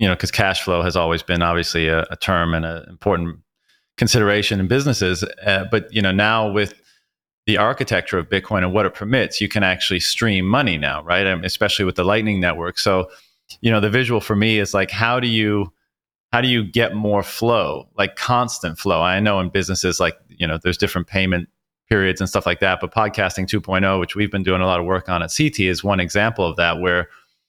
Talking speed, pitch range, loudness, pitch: 225 wpm, 90-105 Hz, -19 LUFS, 95 Hz